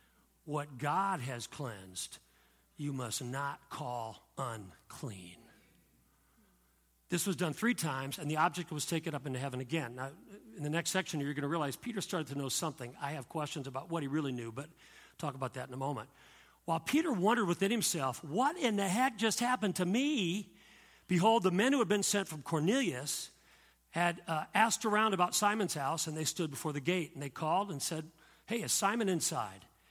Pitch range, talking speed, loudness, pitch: 140-195 Hz, 195 wpm, -34 LUFS, 160 Hz